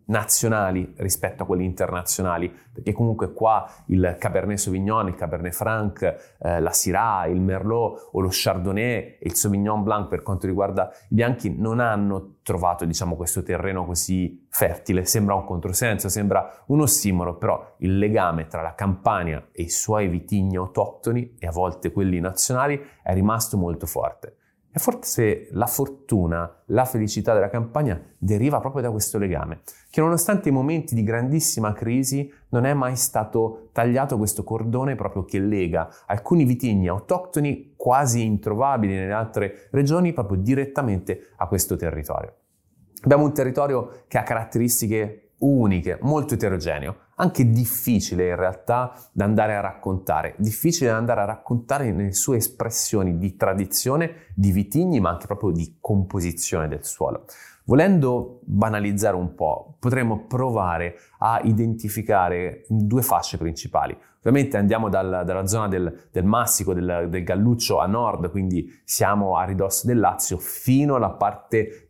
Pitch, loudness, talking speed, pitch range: 105 Hz, -23 LUFS, 150 wpm, 95-120 Hz